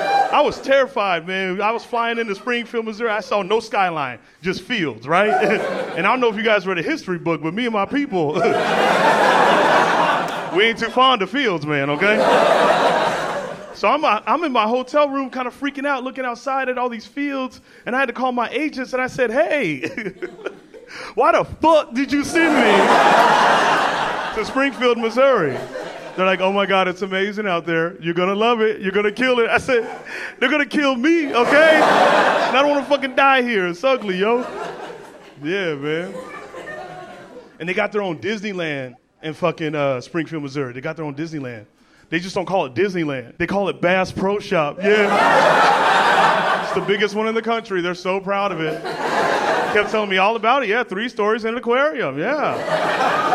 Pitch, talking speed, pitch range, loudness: 215 Hz, 190 wpm, 185-255 Hz, -18 LUFS